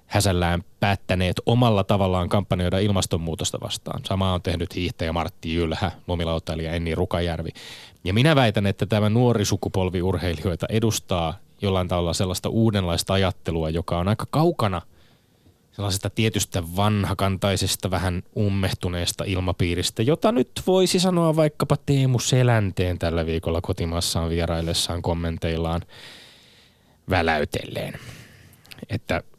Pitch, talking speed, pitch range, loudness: 95 Hz, 110 wpm, 85-110 Hz, -23 LUFS